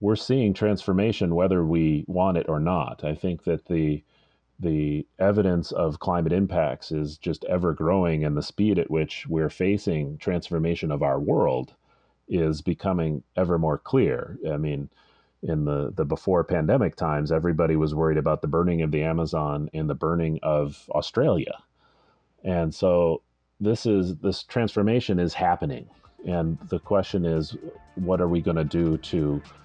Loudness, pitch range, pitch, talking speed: -25 LUFS, 75-90 Hz, 80 Hz, 160 wpm